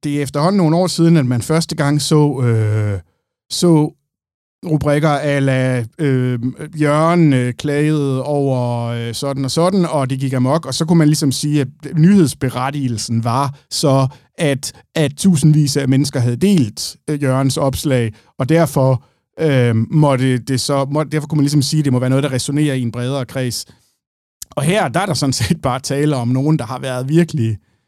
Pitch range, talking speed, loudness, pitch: 130-155 Hz, 185 wpm, -16 LUFS, 140 Hz